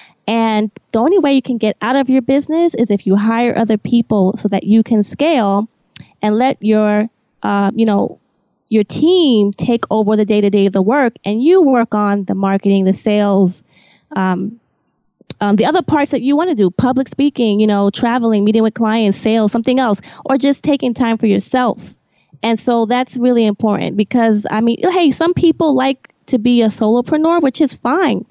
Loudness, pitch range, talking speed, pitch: -14 LUFS, 205-260 Hz, 195 wpm, 225 Hz